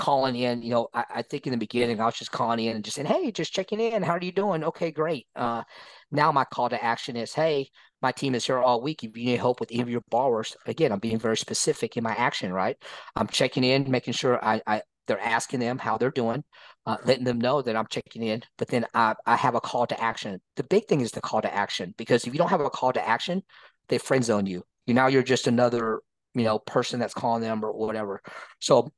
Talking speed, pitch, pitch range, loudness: 260 wpm, 120 Hz, 115-135 Hz, -26 LUFS